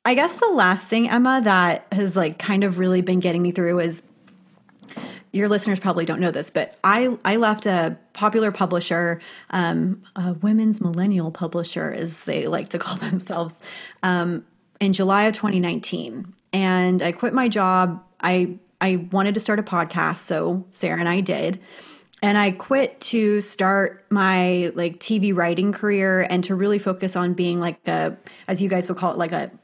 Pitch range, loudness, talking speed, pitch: 175-205 Hz, -21 LUFS, 180 wpm, 185 Hz